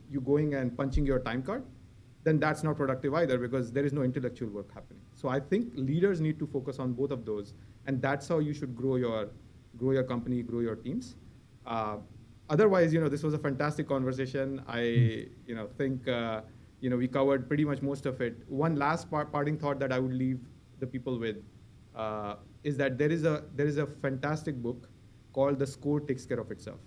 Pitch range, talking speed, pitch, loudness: 120-145 Hz, 215 wpm, 130 Hz, -32 LUFS